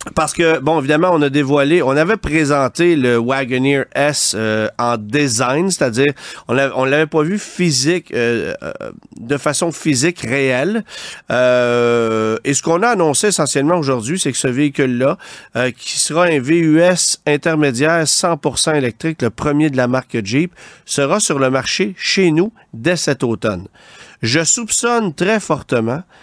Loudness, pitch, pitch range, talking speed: -15 LUFS, 150 Hz, 130-170 Hz, 155 wpm